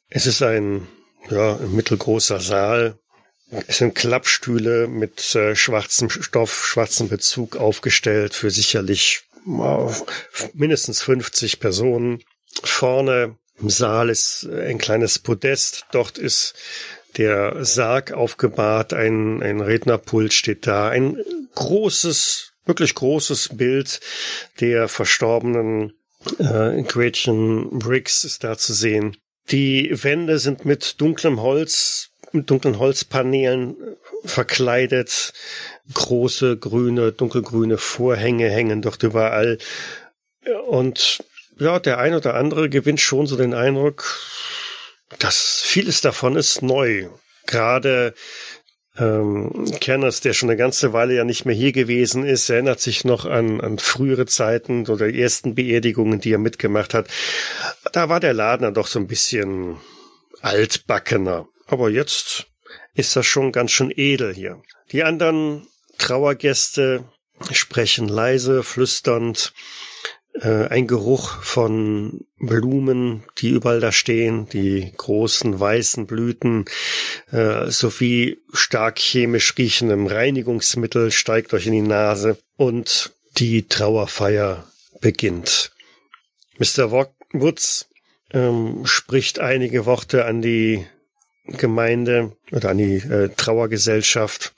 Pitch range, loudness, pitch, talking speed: 110-130 Hz, -18 LUFS, 120 Hz, 115 wpm